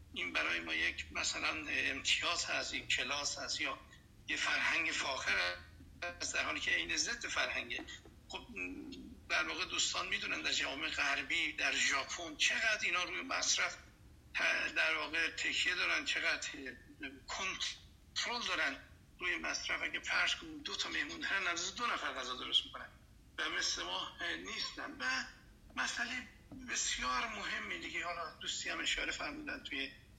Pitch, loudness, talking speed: 240 Hz, -36 LUFS, 140 wpm